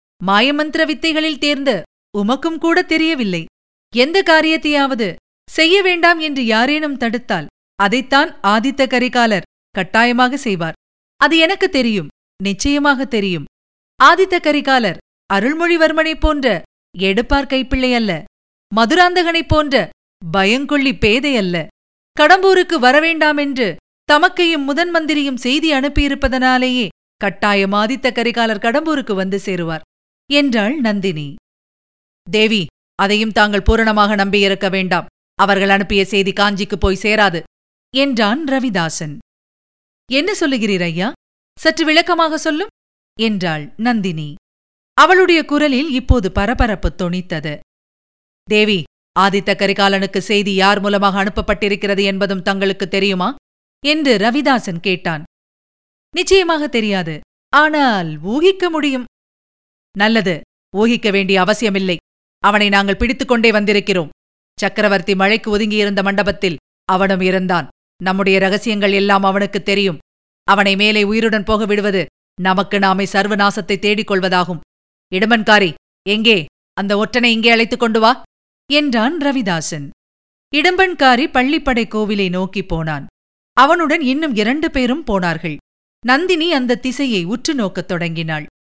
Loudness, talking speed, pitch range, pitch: -15 LUFS, 100 wpm, 195-275 Hz, 215 Hz